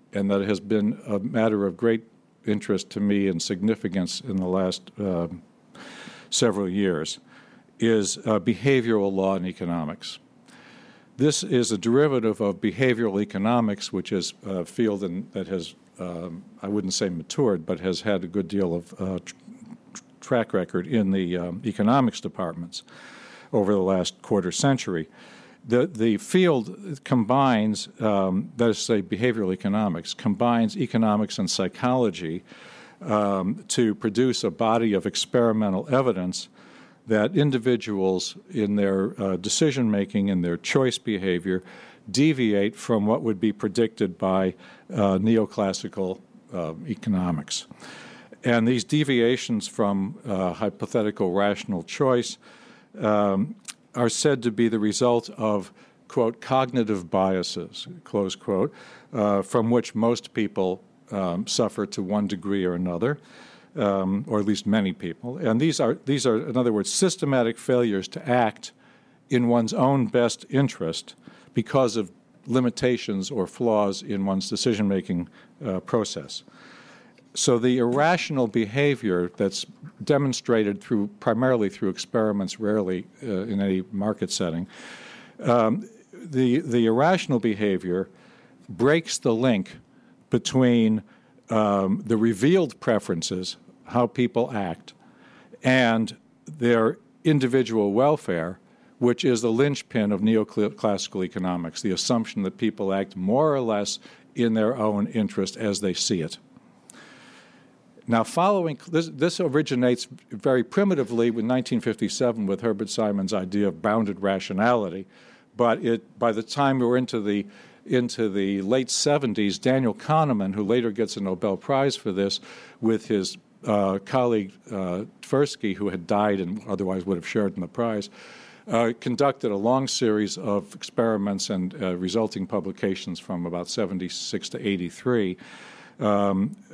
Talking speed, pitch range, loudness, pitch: 135 wpm, 100-125 Hz, -24 LUFS, 110 Hz